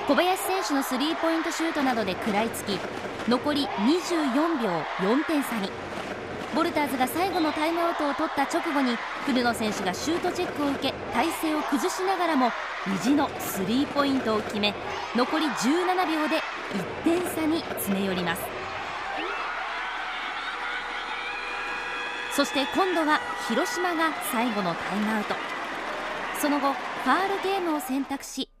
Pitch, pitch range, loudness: 285 Hz, 240-330 Hz, -27 LUFS